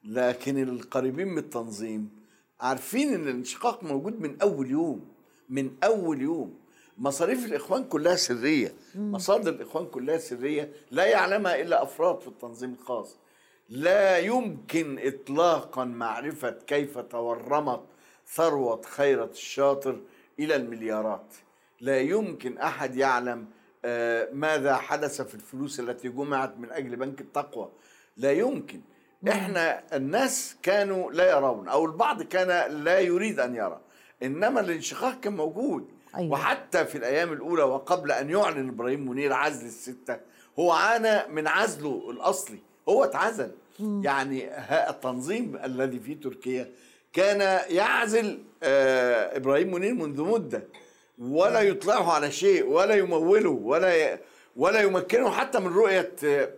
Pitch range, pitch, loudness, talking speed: 130-210 Hz, 150 Hz, -27 LUFS, 120 wpm